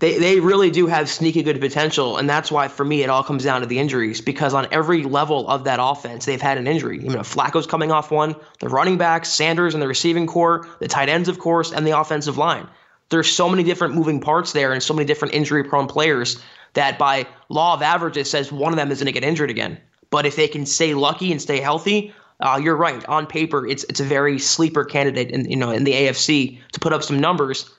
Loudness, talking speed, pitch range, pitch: -19 LUFS, 245 wpm, 140-160 Hz, 150 Hz